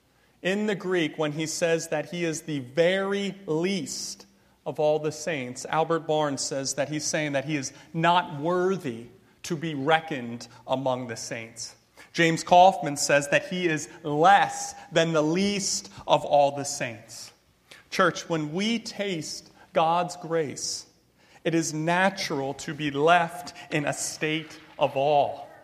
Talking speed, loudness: 150 wpm, -26 LUFS